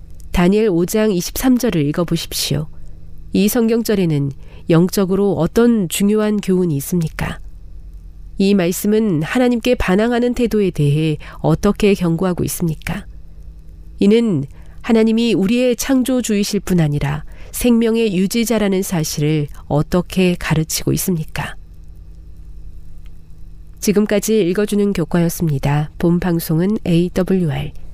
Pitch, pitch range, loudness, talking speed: 175 Hz, 145-210 Hz, -17 LUFS, 265 characters per minute